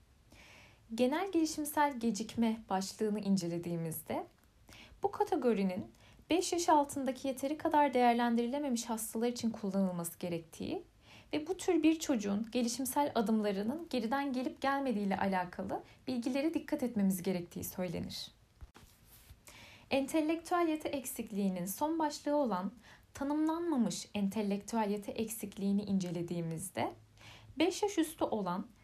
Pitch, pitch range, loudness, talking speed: 235 Hz, 195-290 Hz, -35 LUFS, 100 wpm